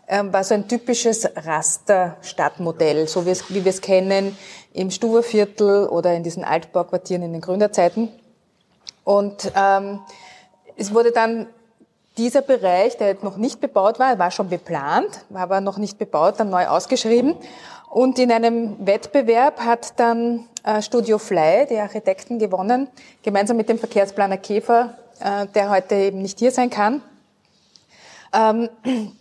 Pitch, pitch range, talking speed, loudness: 210 Hz, 190-235 Hz, 145 wpm, -19 LUFS